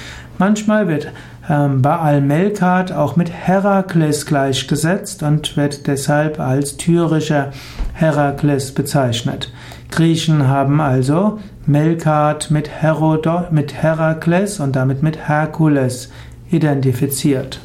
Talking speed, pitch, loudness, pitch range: 95 wpm, 150 Hz, -16 LUFS, 140-165 Hz